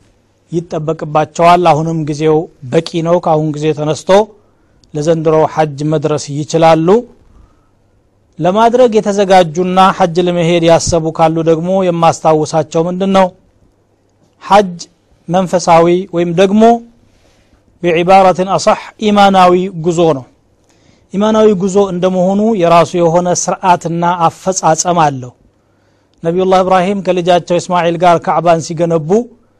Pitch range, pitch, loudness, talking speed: 155-185 Hz, 170 Hz, -11 LUFS, 85 wpm